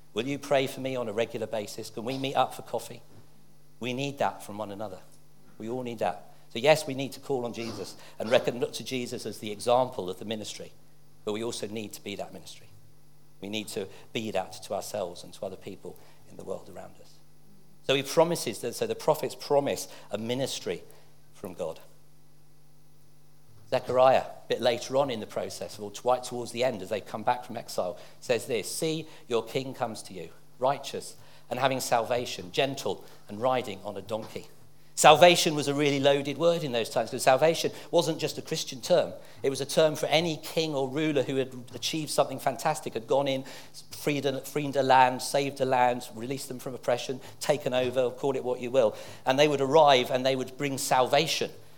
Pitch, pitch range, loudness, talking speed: 130 Hz, 120-145 Hz, -28 LUFS, 205 wpm